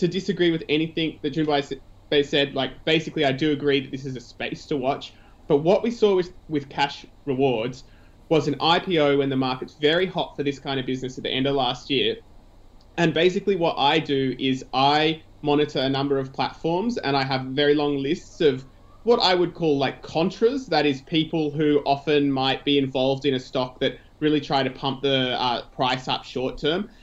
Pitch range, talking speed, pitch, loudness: 135-160 Hz, 205 wpm, 145 Hz, -23 LUFS